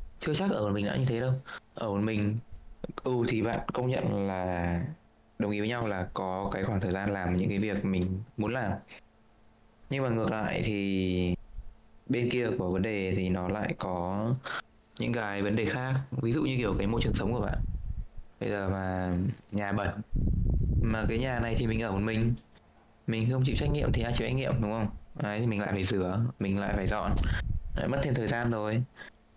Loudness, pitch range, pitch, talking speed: -31 LUFS, 95-115 Hz, 105 Hz, 220 wpm